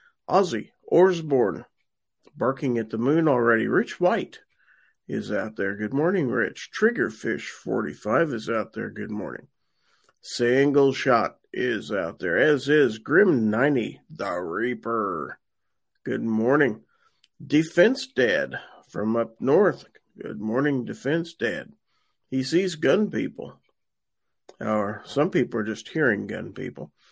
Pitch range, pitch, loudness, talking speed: 115-155 Hz, 135 Hz, -24 LUFS, 120 wpm